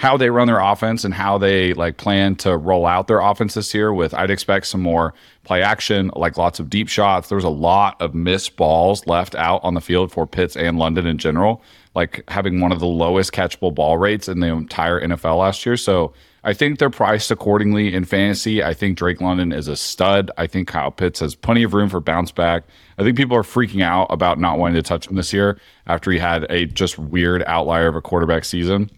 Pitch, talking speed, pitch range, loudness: 90 Hz, 230 wpm, 85-100 Hz, -18 LUFS